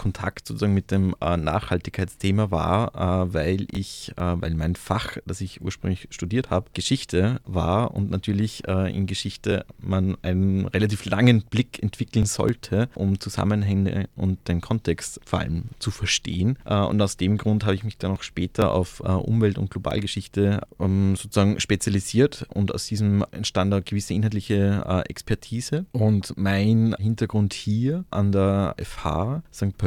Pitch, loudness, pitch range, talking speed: 100 Hz, -24 LUFS, 95-110 Hz, 140 wpm